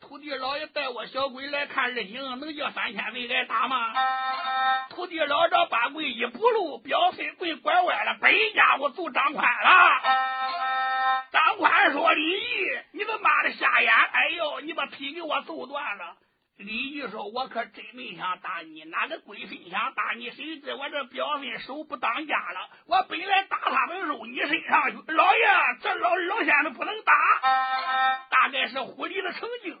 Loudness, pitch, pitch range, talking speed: -24 LUFS, 290 Hz, 260-350 Hz, 240 characters per minute